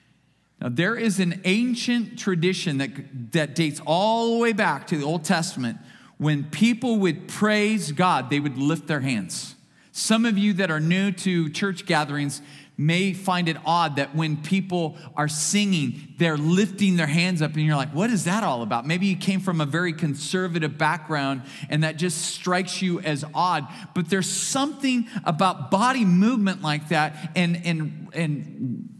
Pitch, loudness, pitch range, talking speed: 175 Hz, -23 LUFS, 155-195 Hz, 180 wpm